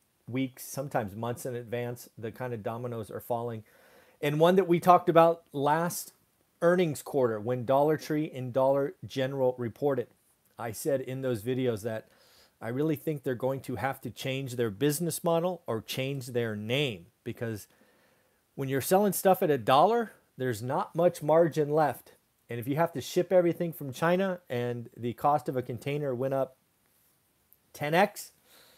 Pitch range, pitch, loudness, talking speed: 120-160 Hz, 135 Hz, -29 LUFS, 165 wpm